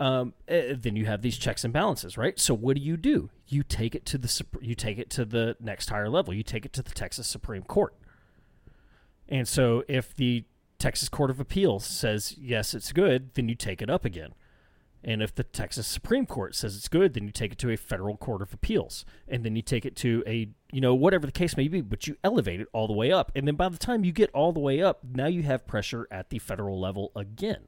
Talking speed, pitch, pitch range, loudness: 245 wpm, 120 Hz, 110-140 Hz, -28 LUFS